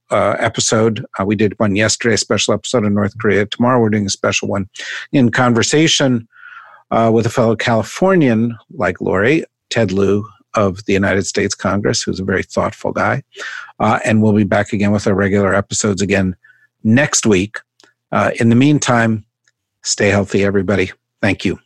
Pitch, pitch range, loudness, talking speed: 110 Hz, 100-115 Hz, -15 LUFS, 170 wpm